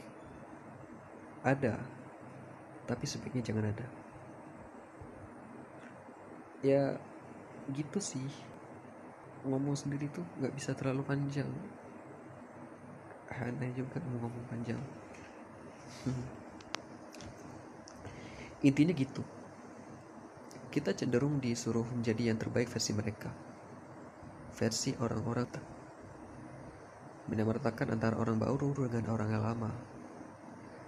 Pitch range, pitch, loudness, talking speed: 115-140 Hz, 125 Hz, -36 LUFS, 80 wpm